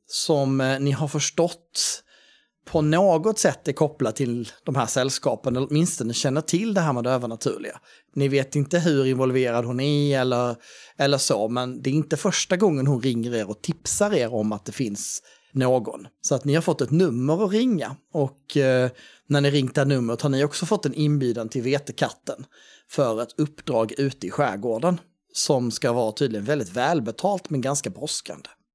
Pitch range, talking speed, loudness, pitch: 130-155 Hz, 185 wpm, -24 LUFS, 140 Hz